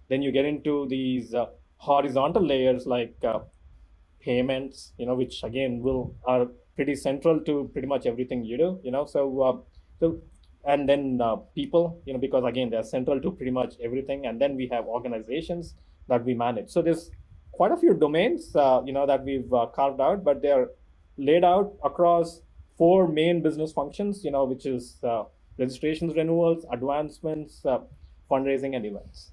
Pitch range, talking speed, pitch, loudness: 125-155 Hz, 180 wpm, 135 Hz, -26 LUFS